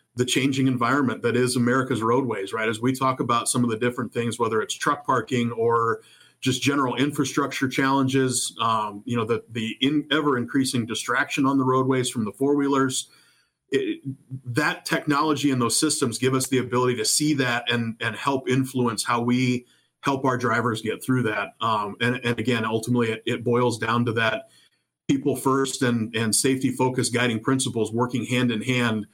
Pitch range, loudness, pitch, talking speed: 115-135 Hz, -23 LUFS, 125 Hz, 185 wpm